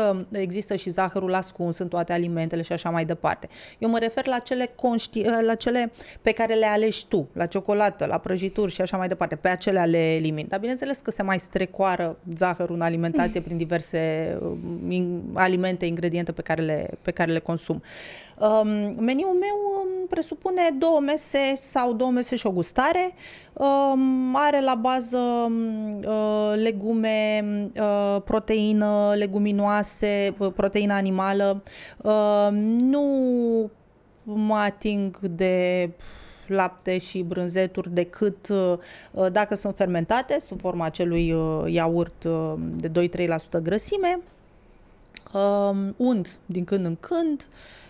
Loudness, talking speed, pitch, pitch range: -24 LUFS, 125 wpm, 200 Hz, 175-225 Hz